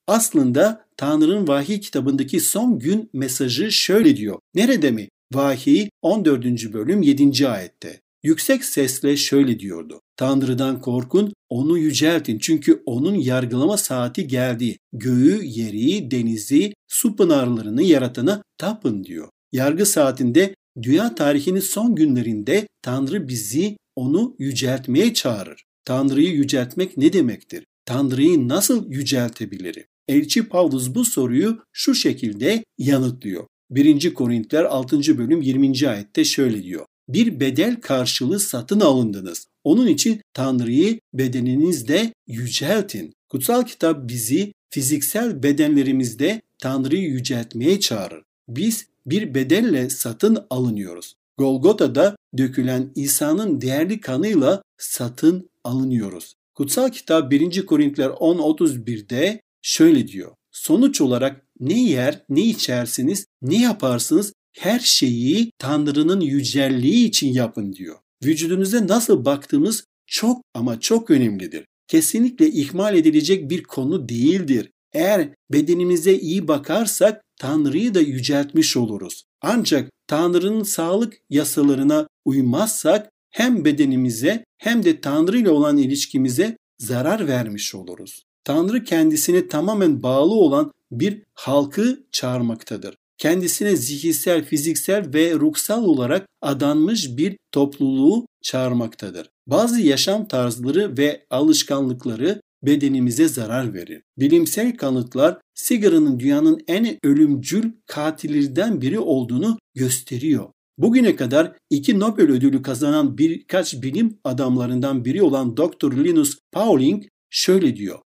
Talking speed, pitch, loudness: 105 wpm, 160 Hz, -19 LUFS